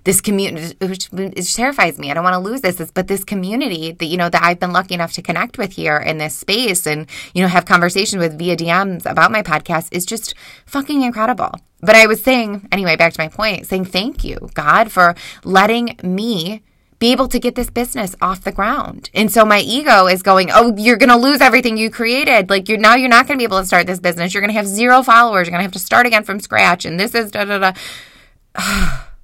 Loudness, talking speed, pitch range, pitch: -14 LUFS, 245 wpm, 180-230 Hz, 195 Hz